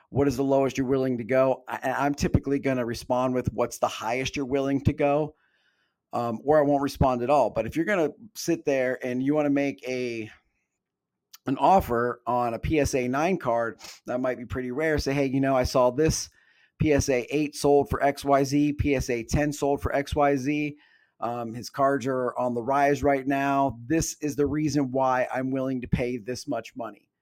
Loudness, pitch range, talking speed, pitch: -26 LUFS, 125-145 Hz, 210 wpm, 135 Hz